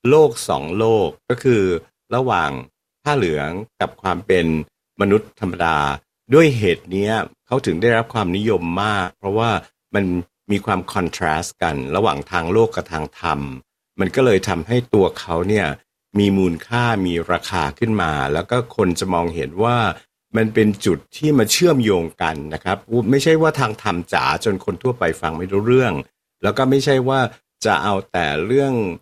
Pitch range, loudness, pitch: 85-115 Hz, -19 LUFS, 100 Hz